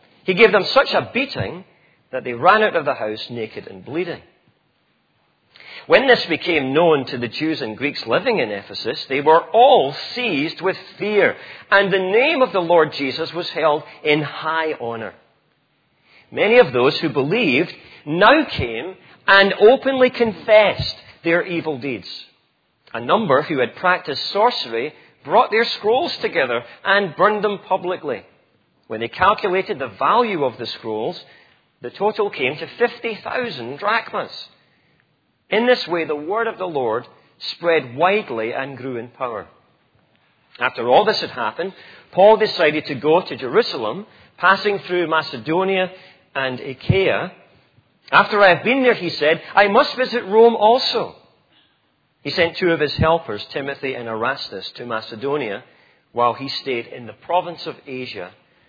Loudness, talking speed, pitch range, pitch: -18 LUFS, 150 wpm, 140-215 Hz, 175 Hz